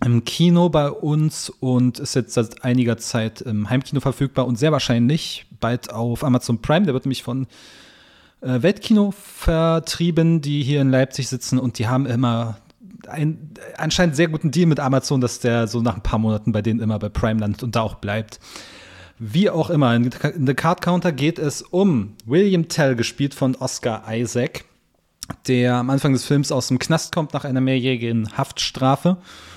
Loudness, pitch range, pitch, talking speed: -20 LUFS, 120-155 Hz, 130 Hz, 180 wpm